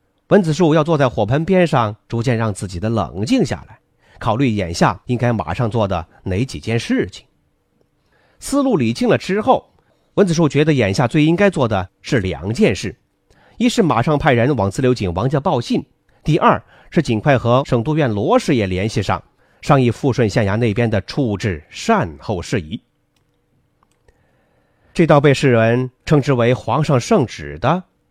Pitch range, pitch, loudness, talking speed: 110-150 Hz, 125 Hz, -17 LUFS, 245 characters per minute